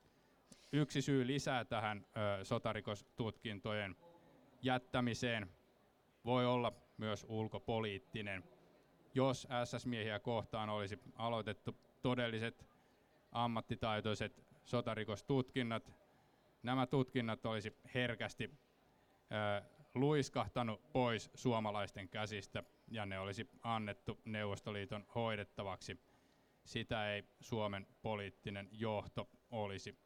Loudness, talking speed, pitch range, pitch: -42 LUFS, 75 wpm, 105-125 Hz, 115 Hz